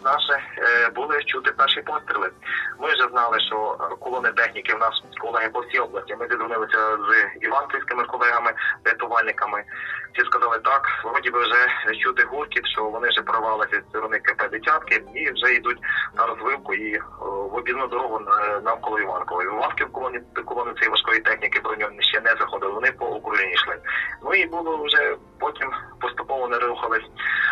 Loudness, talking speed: -22 LUFS, 155 wpm